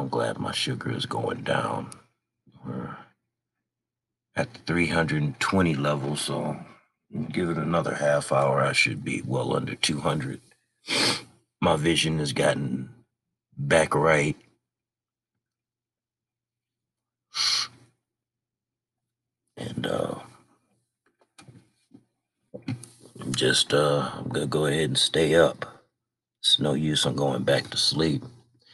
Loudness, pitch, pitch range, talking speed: -25 LUFS, 115 Hz, 75-120 Hz, 105 wpm